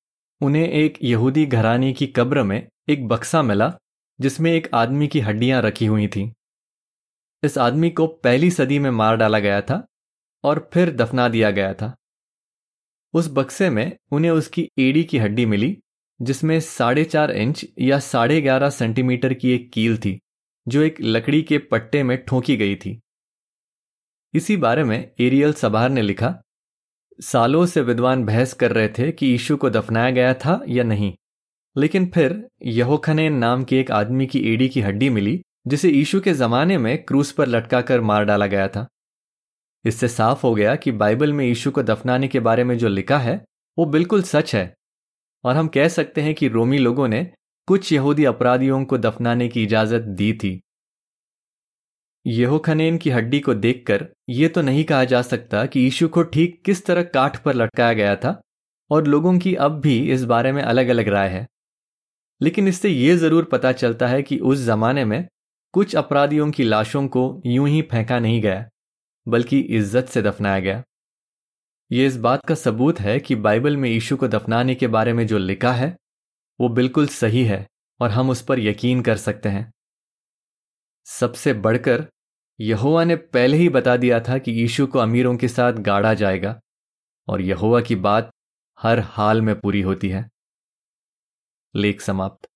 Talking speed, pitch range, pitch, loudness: 175 wpm, 115-145 Hz, 125 Hz, -19 LUFS